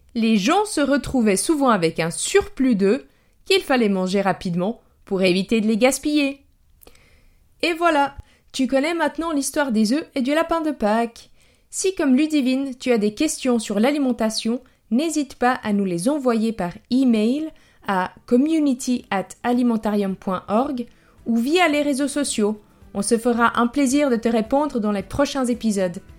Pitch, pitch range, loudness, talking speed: 245 Hz, 215-285 Hz, -21 LUFS, 155 wpm